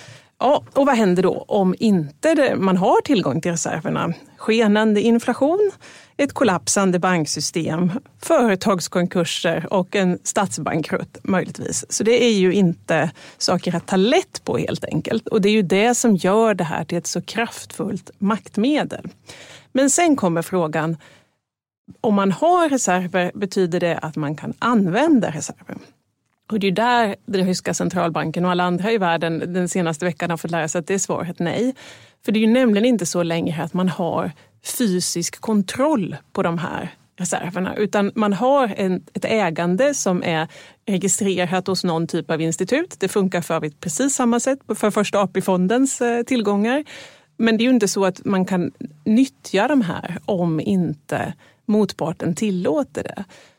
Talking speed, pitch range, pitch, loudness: 160 wpm, 175-225 Hz, 190 Hz, -20 LUFS